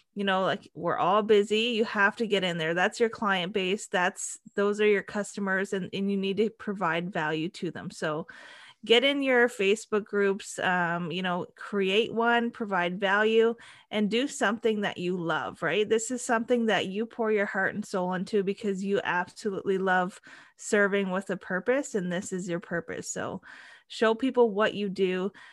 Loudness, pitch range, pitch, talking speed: -27 LUFS, 185-220 Hz, 200 Hz, 190 wpm